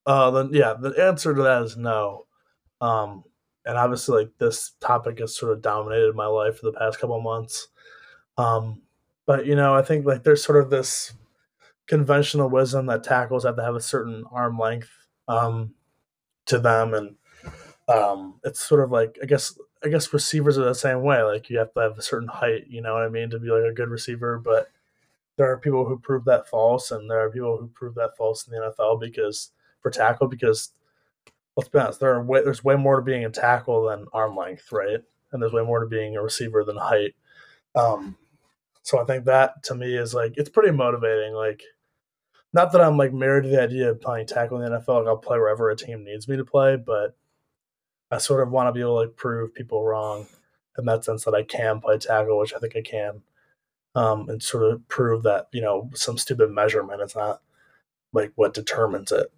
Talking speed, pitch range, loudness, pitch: 220 wpm, 110-135 Hz, -23 LUFS, 120 Hz